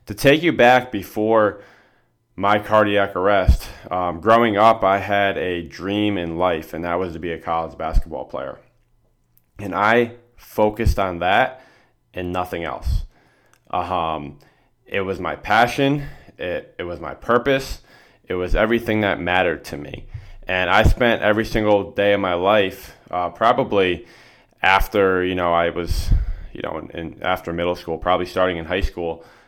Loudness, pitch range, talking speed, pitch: -20 LUFS, 85-110 Hz, 160 wpm, 95 Hz